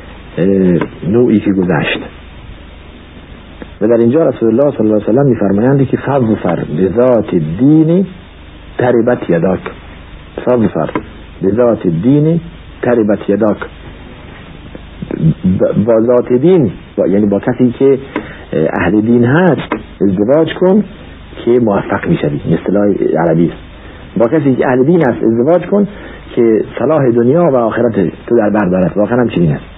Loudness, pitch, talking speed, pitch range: -12 LUFS, 115 Hz, 135 wpm, 95-130 Hz